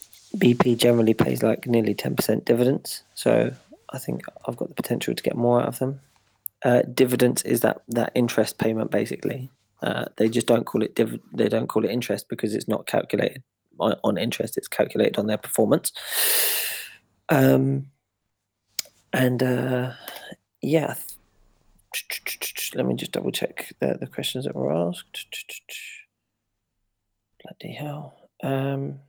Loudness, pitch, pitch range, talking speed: -24 LUFS, 125 Hz, 110-130 Hz, 145 wpm